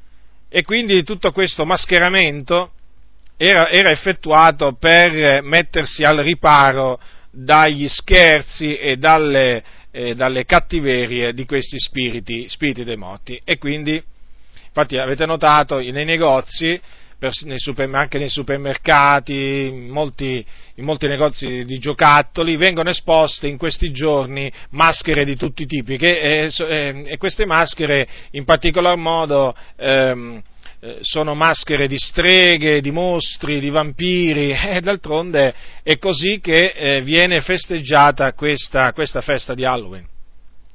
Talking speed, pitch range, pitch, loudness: 120 wpm, 135-165 Hz, 150 Hz, -15 LUFS